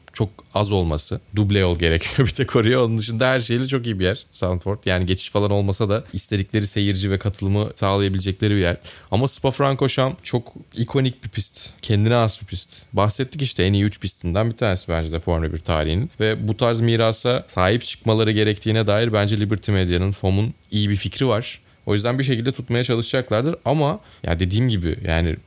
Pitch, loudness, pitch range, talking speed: 105 Hz, -21 LUFS, 95-120 Hz, 190 wpm